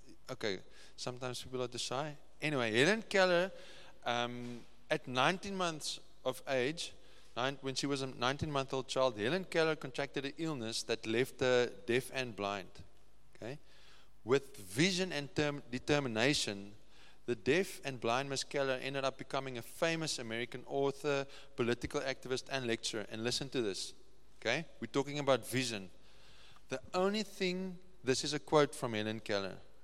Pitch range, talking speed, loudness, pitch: 120-150 Hz, 150 wpm, -36 LUFS, 135 Hz